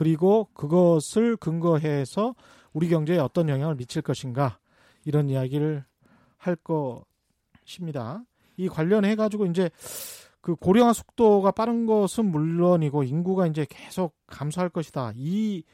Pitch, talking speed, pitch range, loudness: 170 Hz, 280 characters per minute, 150-200 Hz, -25 LUFS